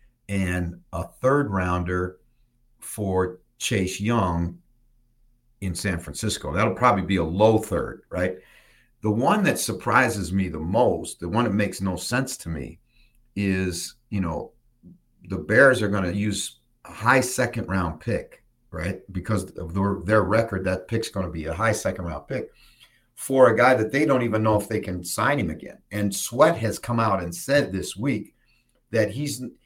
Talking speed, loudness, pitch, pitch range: 175 wpm, -24 LUFS, 105 Hz, 95-120 Hz